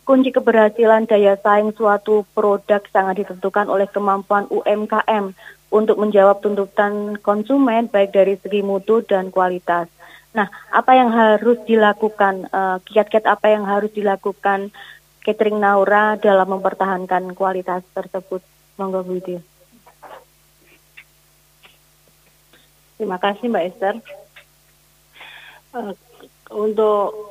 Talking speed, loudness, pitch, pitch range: 100 wpm, -17 LUFS, 205 Hz, 195-215 Hz